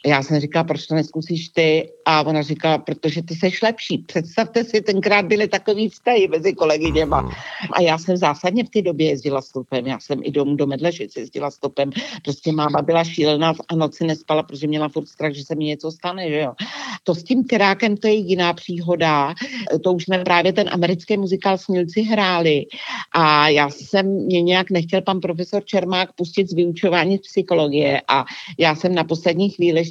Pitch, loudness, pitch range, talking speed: 170 Hz, -19 LUFS, 155-195 Hz, 190 wpm